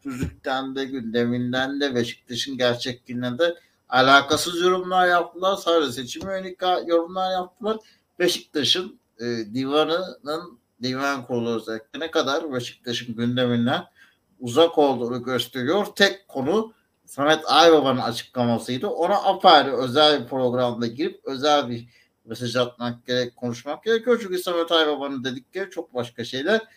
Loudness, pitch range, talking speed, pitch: -22 LUFS, 125-175 Hz, 120 wpm, 135 Hz